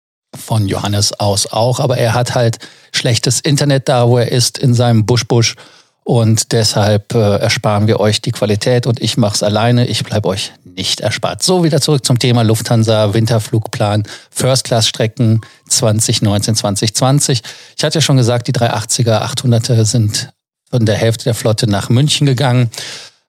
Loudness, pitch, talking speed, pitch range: -13 LUFS, 120 Hz, 165 wpm, 110-125 Hz